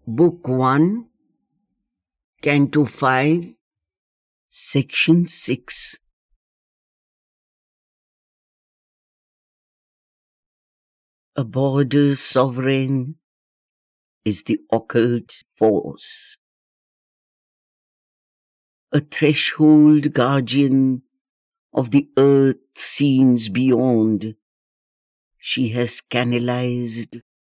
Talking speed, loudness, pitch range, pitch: 50 wpm, -18 LUFS, 120-150 Hz, 135 Hz